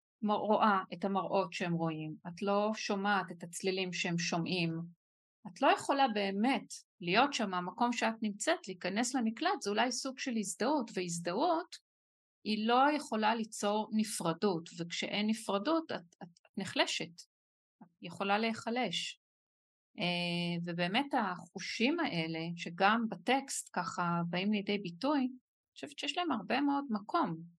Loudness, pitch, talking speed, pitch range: -34 LUFS, 205 Hz, 130 wpm, 175-245 Hz